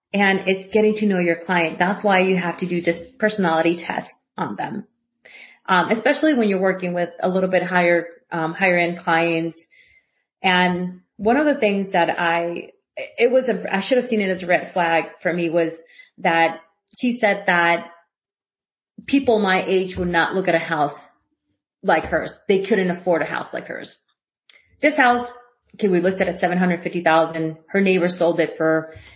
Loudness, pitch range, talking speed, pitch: -20 LUFS, 170-210 Hz, 190 wpm, 180 Hz